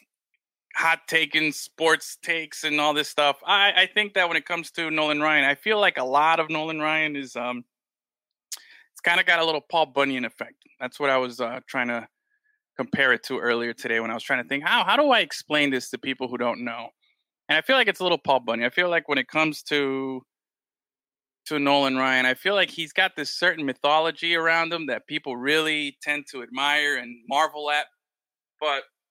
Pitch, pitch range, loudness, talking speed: 150 Hz, 135-165 Hz, -23 LUFS, 215 wpm